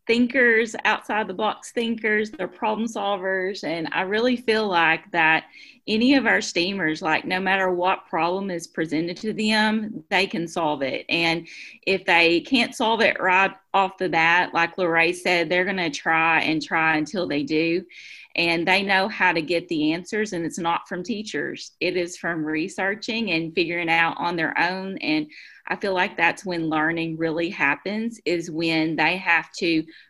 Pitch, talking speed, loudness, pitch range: 180 Hz, 180 wpm, -22 LUFS, 165-215 Hz